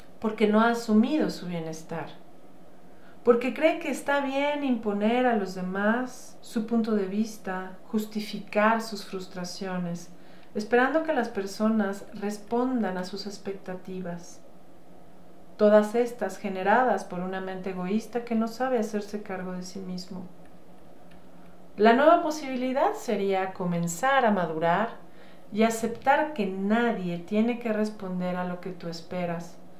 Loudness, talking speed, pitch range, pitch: -27 LUFS, 130 wpm, 185-230 Hz, 210 Hz